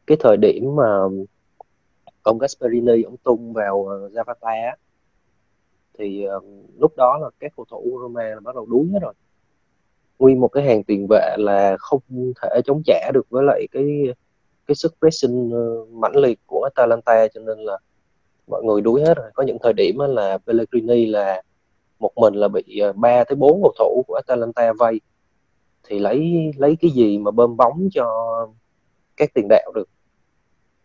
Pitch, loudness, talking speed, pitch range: 115 Hz, -18 LUFS, 175 wpm, 105-130 Hz